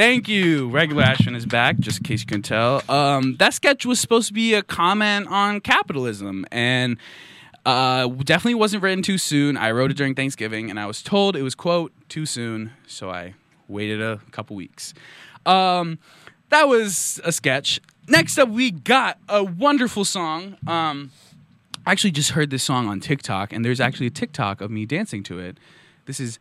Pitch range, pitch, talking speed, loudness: 120-195 Hz, 145 Hz, 190 wpm, -20 LUFS